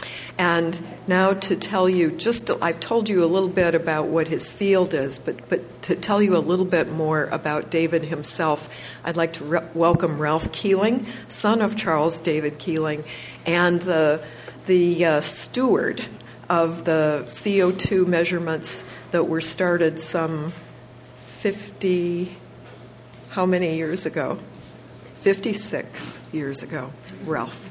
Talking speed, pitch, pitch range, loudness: 140 wpm, 165 Hz, 155-180 Hz, -21 LUFS